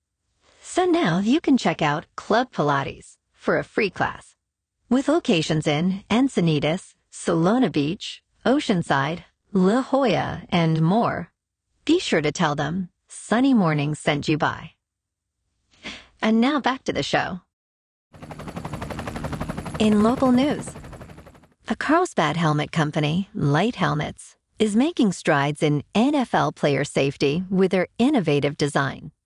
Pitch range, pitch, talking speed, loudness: 150-240 Hz, 180 Hz, 120 wpm, -22 LUFS